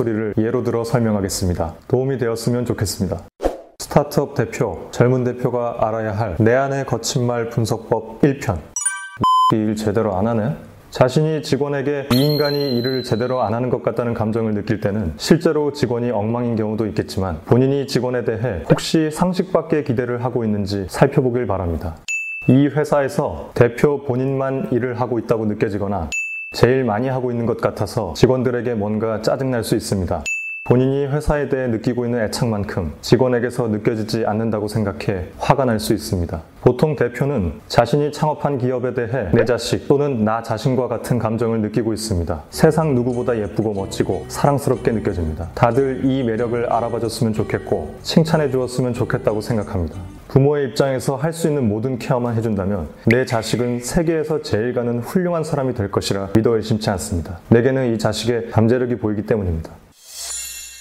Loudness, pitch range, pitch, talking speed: -19 LUFS, 110-135 Hz, 120 Hz, 375 characters per minute